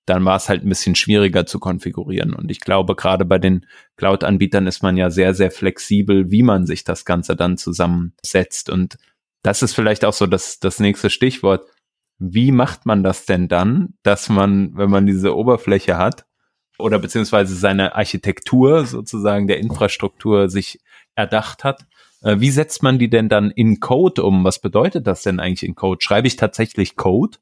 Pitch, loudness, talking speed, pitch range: 100 Hz, -17 LUFS, 180 wpm, 95-110 Hz